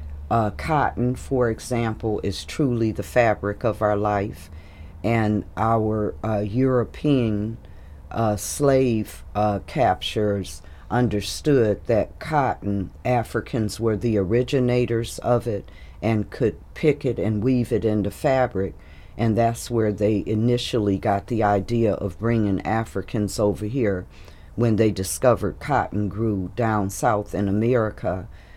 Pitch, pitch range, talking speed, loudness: 105 Hz, 100-115 Hz, 125 wpm, -23 LUFS